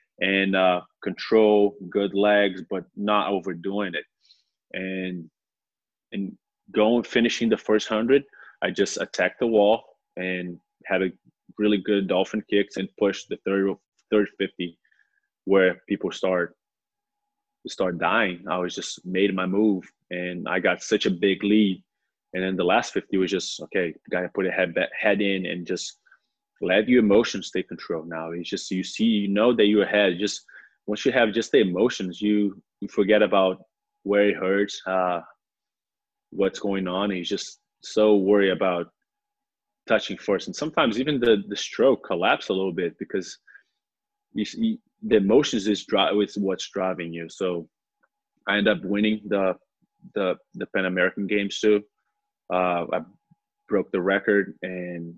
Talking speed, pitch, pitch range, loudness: 160 wpm, 100 Hz, 95-110 Hz, -24 LUFS